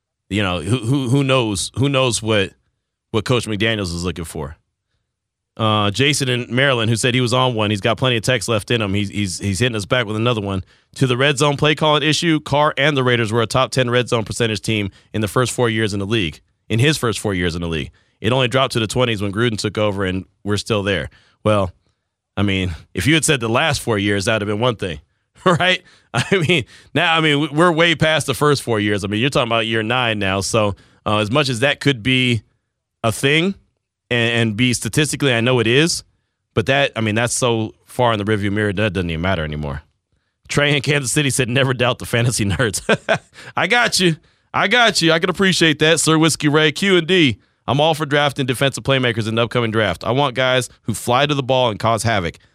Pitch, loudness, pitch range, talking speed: 115 Hz, -17 LUFS, 105-140 Hz, 240 wpm